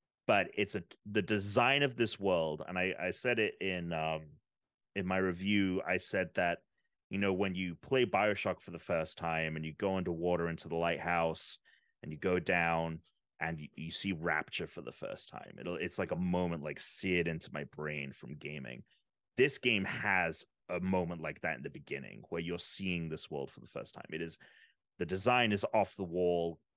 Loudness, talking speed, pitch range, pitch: -35 LUFS, 200 wpm, 80-95 Hz, 90 Hz